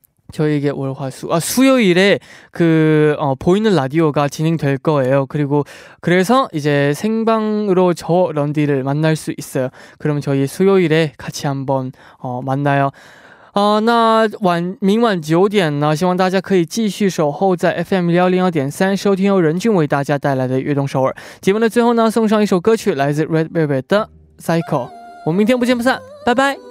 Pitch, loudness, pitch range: 165 Hz, -16 LUFS, 145-200 Hz